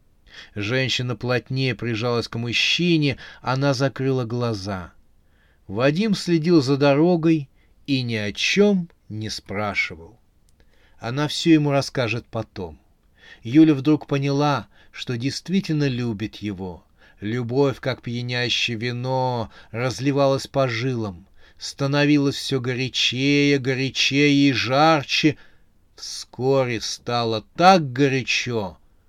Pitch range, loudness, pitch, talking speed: 110-140 Hz, -21 LUFS, 125 Hz, 95 wpm